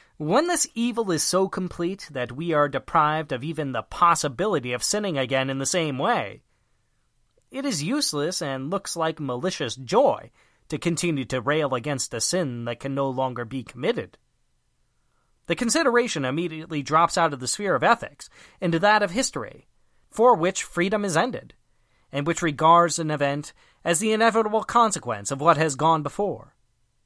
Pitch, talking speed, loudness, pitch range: 160 Hz, 165 wpm, -23 LUFS, 135-185 Hz